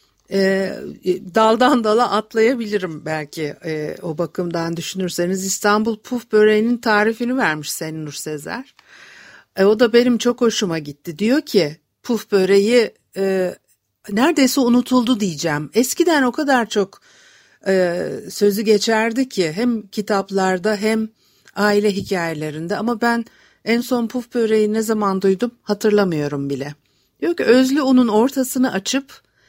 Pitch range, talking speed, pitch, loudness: 185-240 Hz, 125 wpm, 210 Hz, -18 LUFS